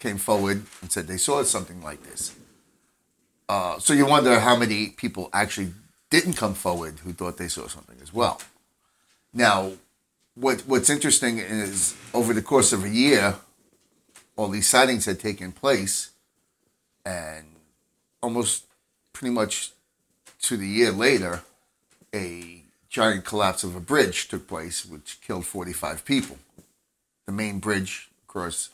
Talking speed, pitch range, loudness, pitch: 145 wpm, 90-110 Hz, -23 LUFS, 100 Hz